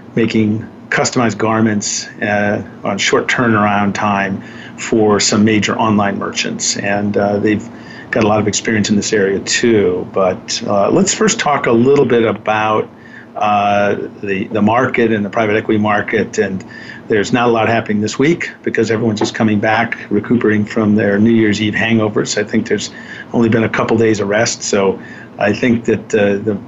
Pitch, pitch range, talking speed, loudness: 110 Hz, 105-115 Hz, 180 wpm, -14 LUFS